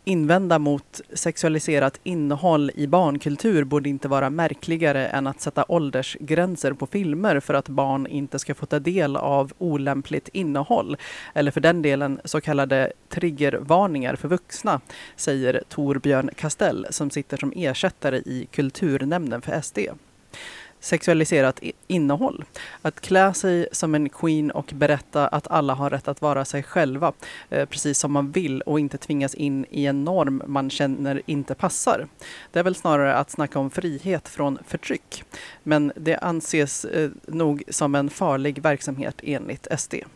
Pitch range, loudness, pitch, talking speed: 140-165 Hz, -23 LUFS, 145 Hz, 150 wpm